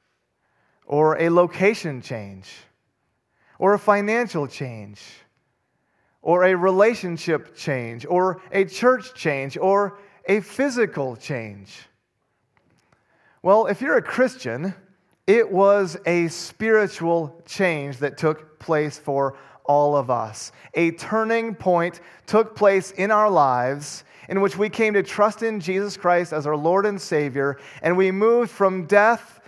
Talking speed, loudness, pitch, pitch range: 130 wpm, -21 LUFS, 180 Hz, 145-205 Hz